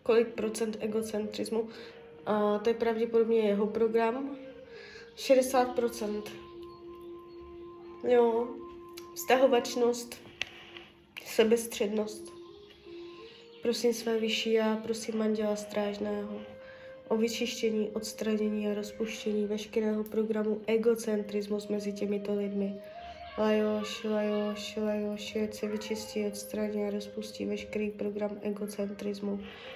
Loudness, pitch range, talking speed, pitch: -31 LUFS, 210-240 Hz, 85 wpm, 220 Hz